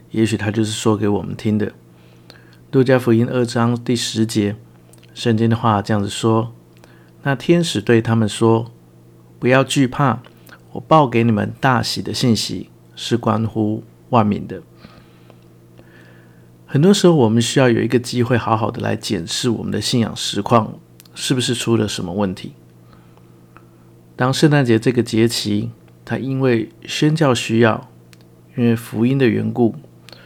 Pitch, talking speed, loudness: 110 Hz, 220 characters per minute, -17 LUFS